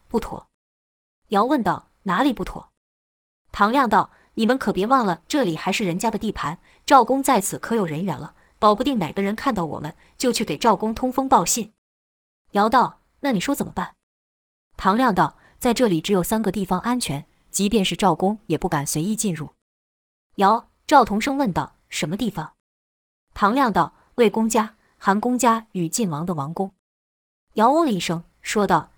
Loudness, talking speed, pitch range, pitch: -21 LUFS, 255 characters per minute, 160-230 Hz, 195 Hz